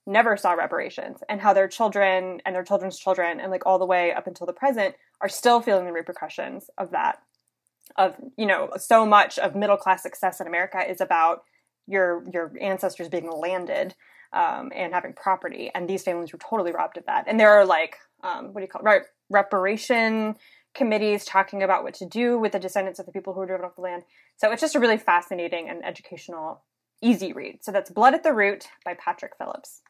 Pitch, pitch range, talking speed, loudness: 195 Hz, 185-220 Hz, 215 wpm, -23 LUFS